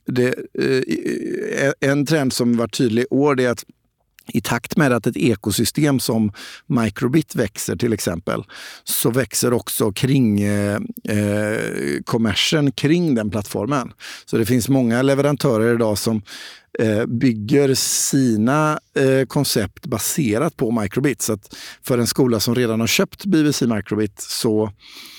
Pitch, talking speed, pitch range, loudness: 120 Hz, 140 wpm, 110-140 Hz, -19 LUFS